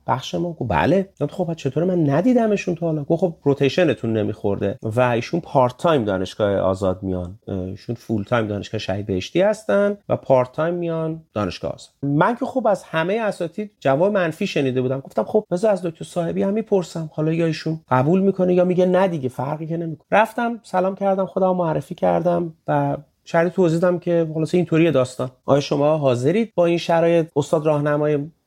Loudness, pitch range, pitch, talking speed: -20 LUFS, 130-180 Hz, 160 Hz, 185 wpm